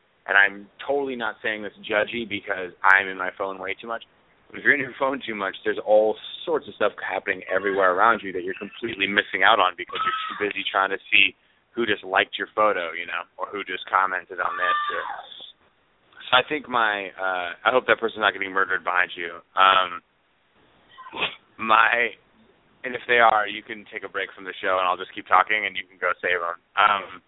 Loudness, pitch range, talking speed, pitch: -23 LUFS, 95-130 Hz, 215 wpm, 100 Hz